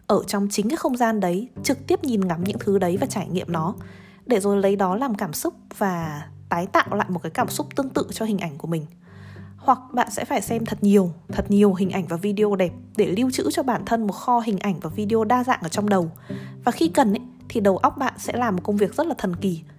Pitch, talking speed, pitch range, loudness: 205 Hz, 265 wpm, 185-240 Hz, -23 LUFS